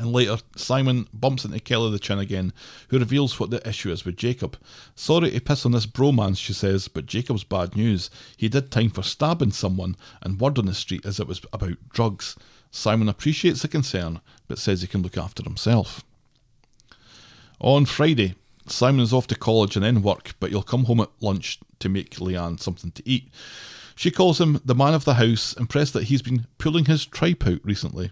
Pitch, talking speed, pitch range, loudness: 115 Hz, 205 wpm, 100-130 Hz, -23 LUFS